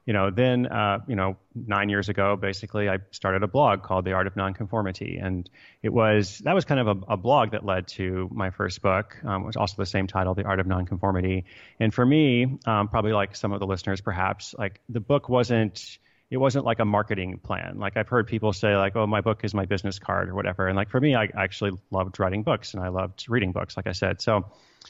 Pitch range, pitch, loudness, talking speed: 95-110 Hz, 100 Hz, -25 LUFS, 240 wpm